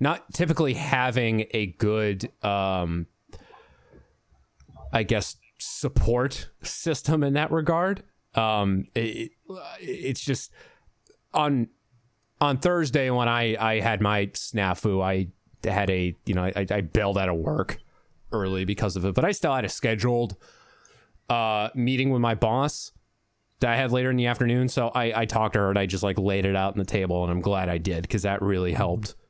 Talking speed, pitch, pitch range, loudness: 170 wpm, 110 Hz, 100-125 Hz, -26 LUFS